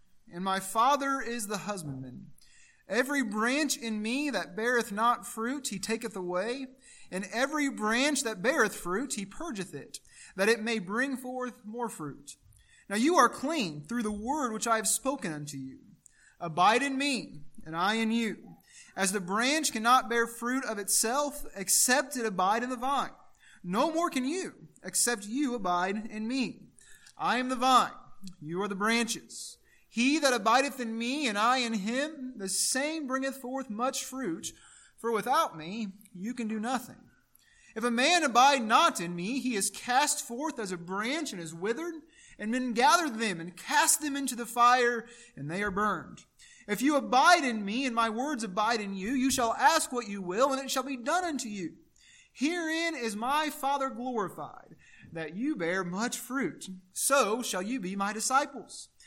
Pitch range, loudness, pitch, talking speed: 205-270 Hz, -29 LUFS, 235 Hz, 180 wpm